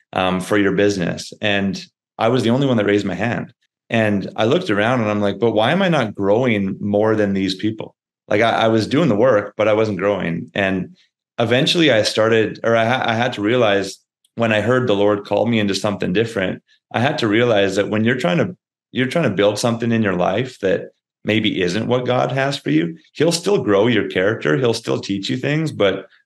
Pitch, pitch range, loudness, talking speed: 110 Hz, 100-125 Hz, -18 LUFS, 225 wpm